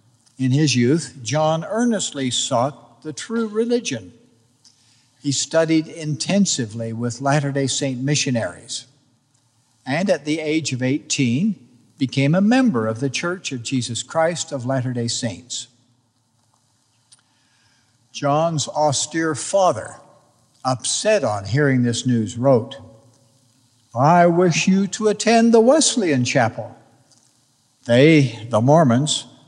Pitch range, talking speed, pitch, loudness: 120-155 Hz, 115 wpm, 130 Hz, -19 LUFS